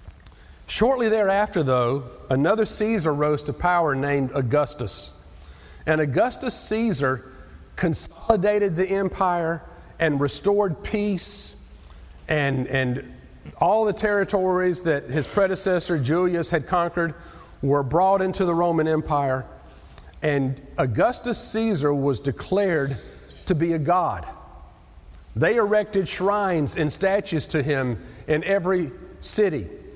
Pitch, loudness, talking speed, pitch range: 165 Hz, -22 LUFS, 110 wpm, 135-195 Hz